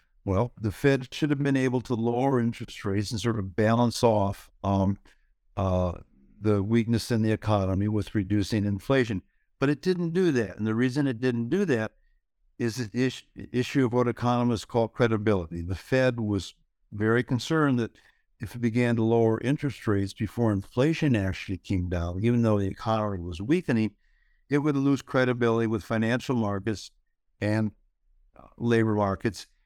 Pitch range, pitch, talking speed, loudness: 100-125 Hz, 115 Hz, 165 wpm, -27 LUFS